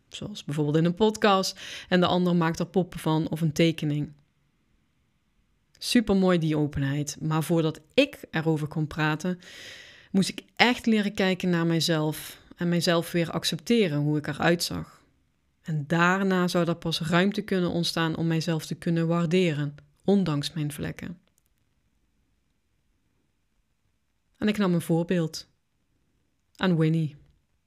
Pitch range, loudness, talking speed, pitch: 155-185 Hz, -26 LUFS, 135 wpm, 170 Hz